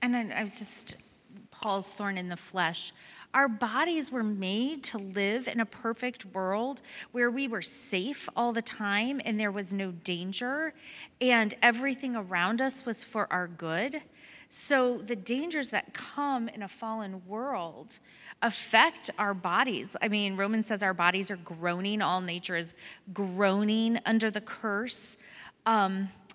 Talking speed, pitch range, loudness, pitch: 155 wpm, 195-245 Hz, -30 LUFS, 220 Hz